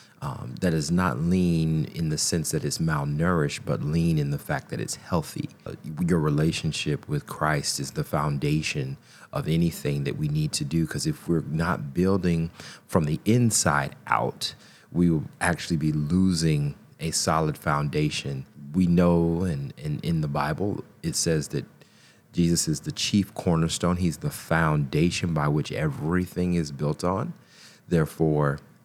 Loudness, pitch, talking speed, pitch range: -26 LUFS, 85 Hz, 160 wpm, 75-95 Hz